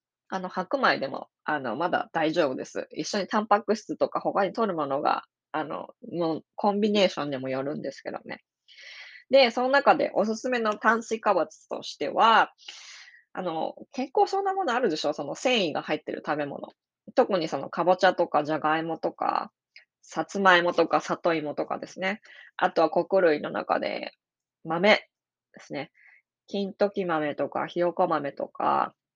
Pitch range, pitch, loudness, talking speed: 165-230 Hz, 195 Hz, -26 LUFS, 315 characters per minute